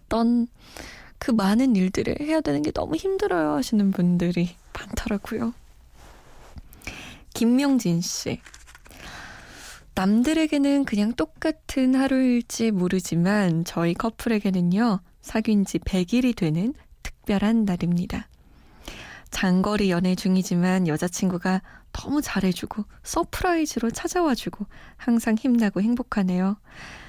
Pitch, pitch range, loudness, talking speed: 215 Hz, 185-250 Hz, -24 LUFS, 255 characters per minute